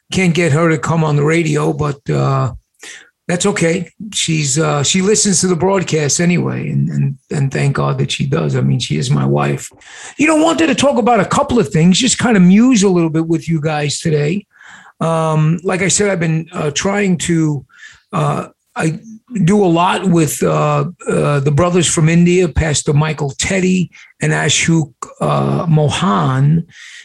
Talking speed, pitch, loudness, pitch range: 185 wpm, 165 Hz, -14 LUFS, 150-190 Hz